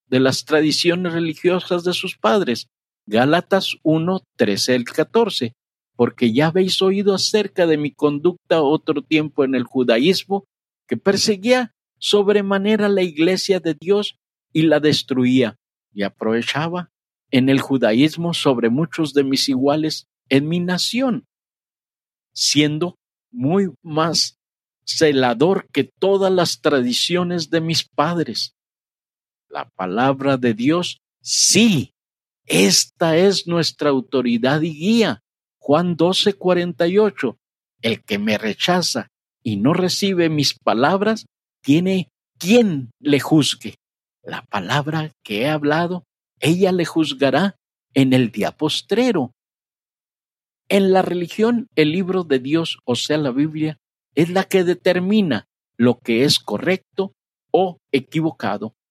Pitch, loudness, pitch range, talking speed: 160 Hz, -18 LUFS, 135-185 Hz, 120 wpm